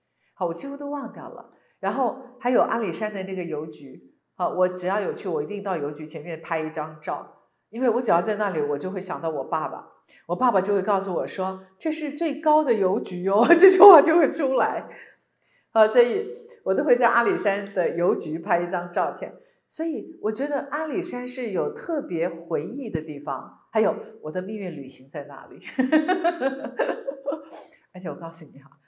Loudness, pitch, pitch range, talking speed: -24 LUFS, 200 Hz, 170-275 Hz, 270 characters per minute